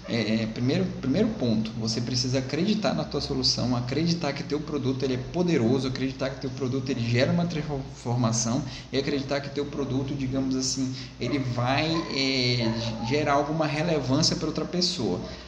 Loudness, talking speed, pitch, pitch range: -26 LUFS, 160 wpm, 135 Hz, 125-145 Hz